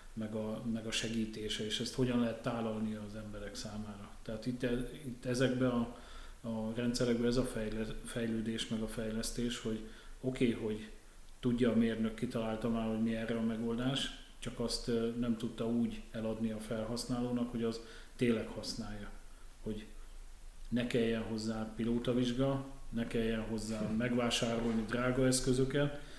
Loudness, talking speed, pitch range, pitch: -36 LUFS, 145 wpm, 110-120 Hz, 115 Hz